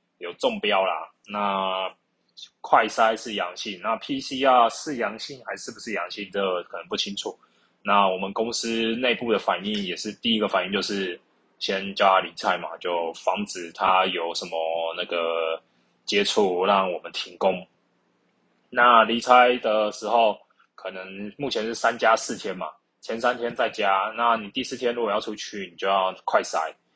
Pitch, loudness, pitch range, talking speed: 100 Hz, -24 LUFS, 95-115 Hz, 240 characters per minute